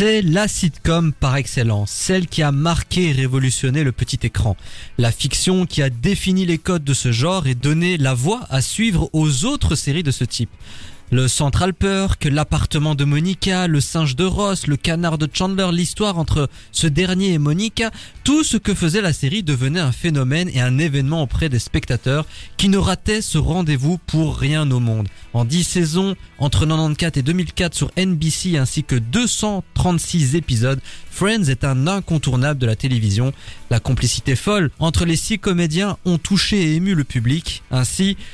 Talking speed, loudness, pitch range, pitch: 180 wpm, -18 LUFS, 130-180 Hz, 150 Hz